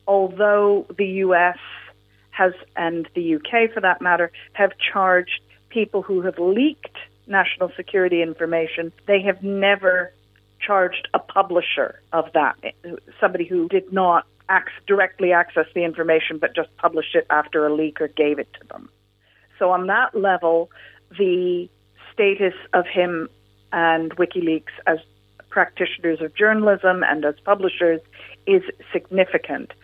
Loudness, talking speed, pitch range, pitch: -20 LUFS, 135 wpm, 165-195 Hz, 180 Hz